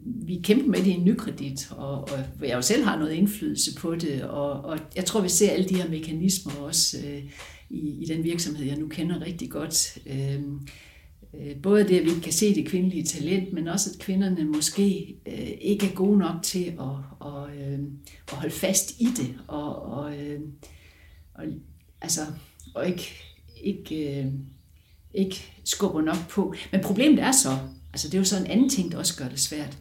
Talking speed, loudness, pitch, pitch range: 195 wpm, -26 LUFS, 155 Hz, 140-190 Hz